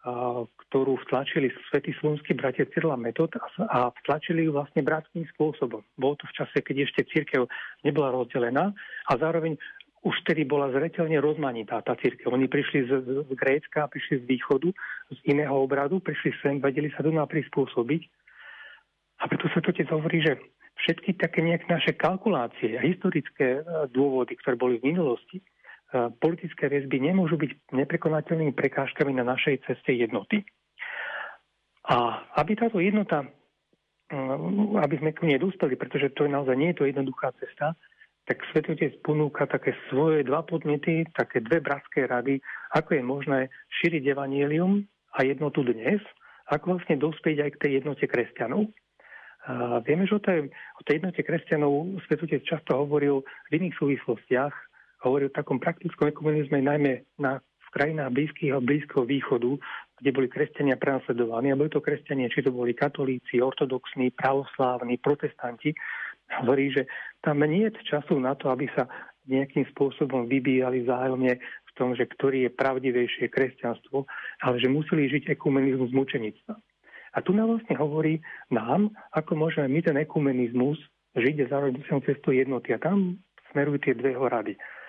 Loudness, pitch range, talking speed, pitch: -27 LUFS, 135-160 Hz, 150 wpm, 145 Hz